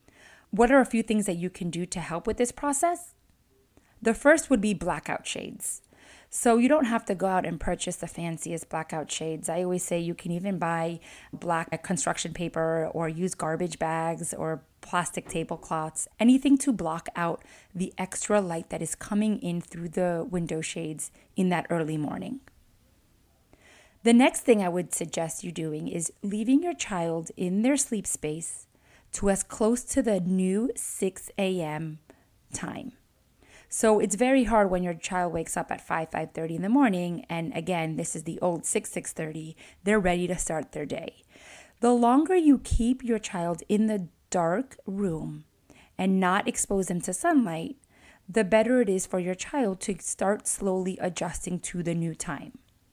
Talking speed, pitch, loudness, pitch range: 175 wpm, 180 Hz, -27 LUFS, 165-220 Hz